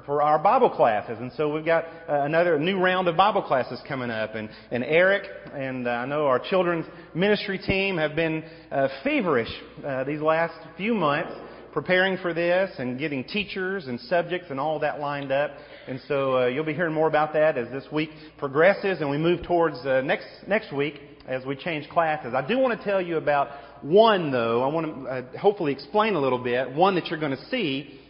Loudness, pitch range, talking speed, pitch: -24 LUFS, 135-175 Hz, 210 wpm, 155 Hz